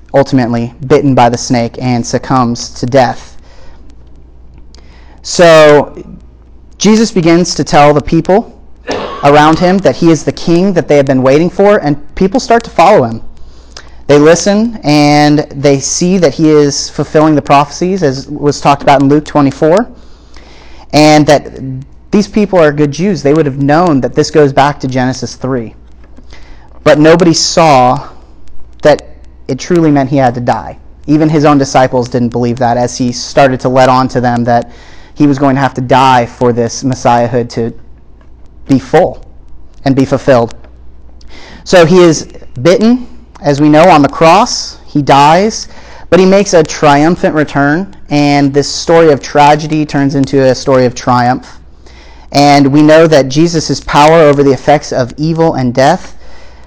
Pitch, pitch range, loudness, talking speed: 140 Hz, 120-150 Hz, -8 LUFS, 165 wpm